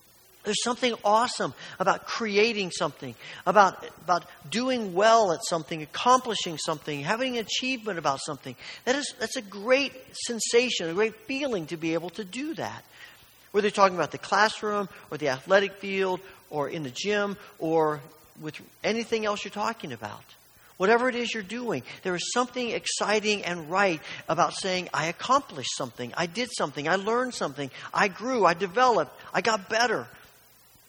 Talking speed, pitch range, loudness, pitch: 165 wpm, 165-225 Hz, -27 LUFS, 200 Hz